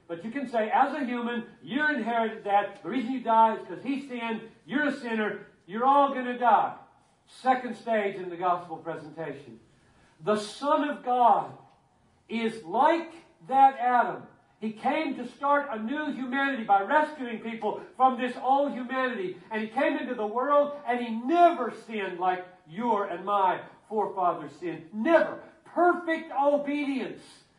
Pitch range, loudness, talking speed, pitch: 205-275 Hz, -27 LUFS, 160 wpm, 240 Hz